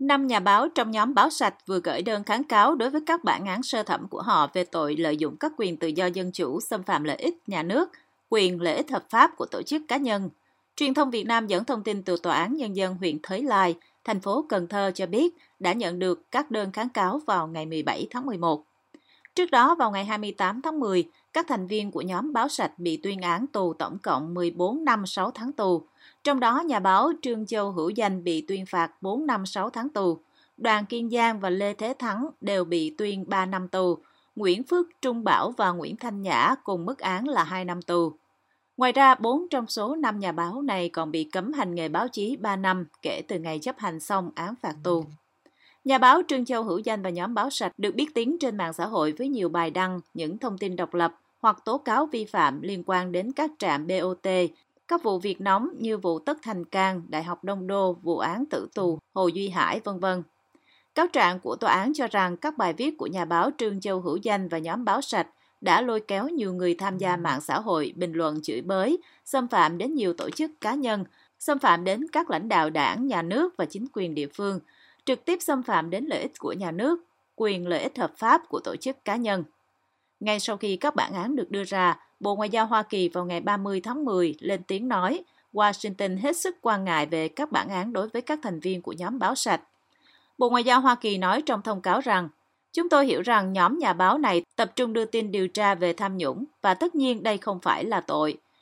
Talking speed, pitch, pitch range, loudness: 235 wpm, 200 Hz, 180-255 Hz, -26 LUFS